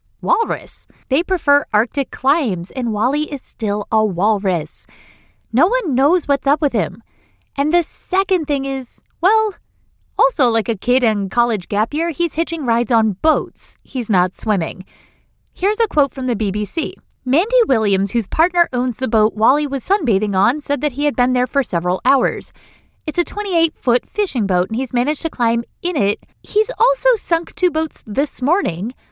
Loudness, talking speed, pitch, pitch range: -18 LUFS, 175 wpm, 265 Hz, 220-330 Hz